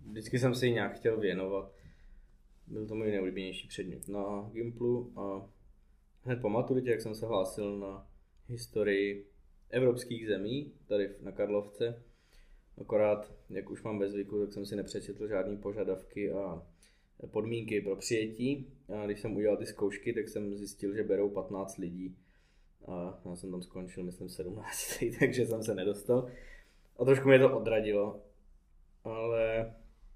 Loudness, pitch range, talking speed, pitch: -34 LUFS, 95-115 Hz, 145 wpm, 100 Hz